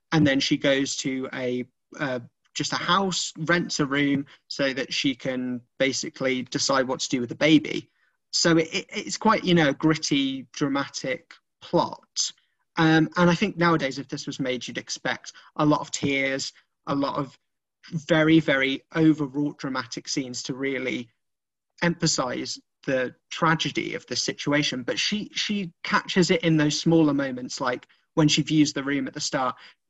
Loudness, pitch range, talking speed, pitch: -25 LUFS, 135-165 Hz, 170 wpm, 145 Hz